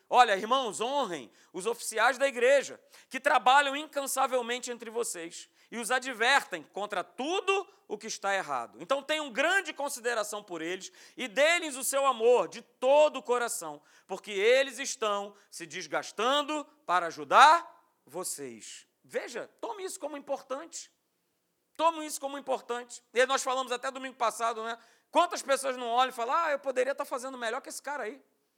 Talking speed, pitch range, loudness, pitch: 160 wpm, 225-290 Hz, -29 LUFS, 260 Hz